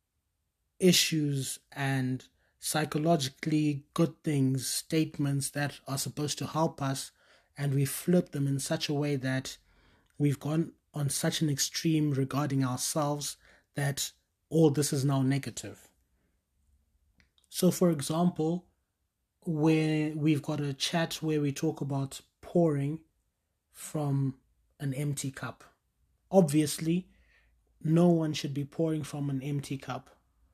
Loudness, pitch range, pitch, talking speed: -30 LUFS, 135-155 Hz, 145 Hz, 120 wpm